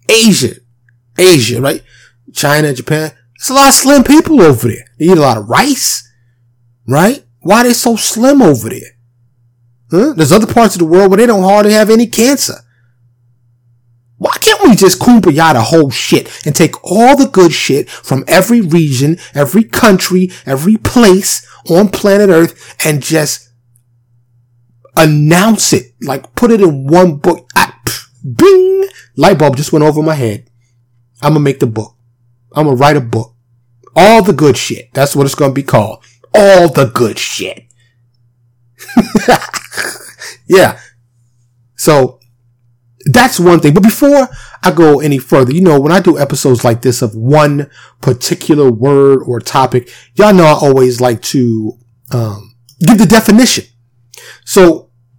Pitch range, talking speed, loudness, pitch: 120-190 Hz, 155 wpm, -9 LUFS, 145 Hz